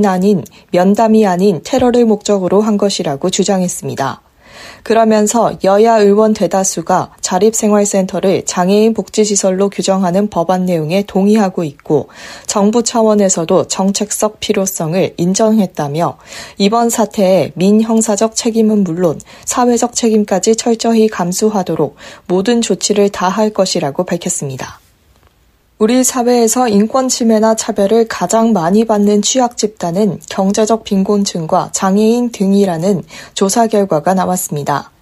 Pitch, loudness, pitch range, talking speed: 200 Hz, -13 LUFS, 185-220 Hz, 310 characters per minute